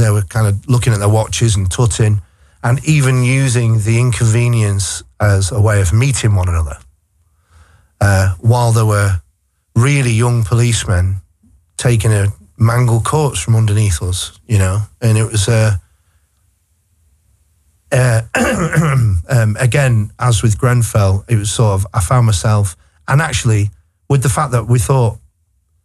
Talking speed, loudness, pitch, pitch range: 145 wpm, -14 LUFS, 105 Hz, 90-120 Hz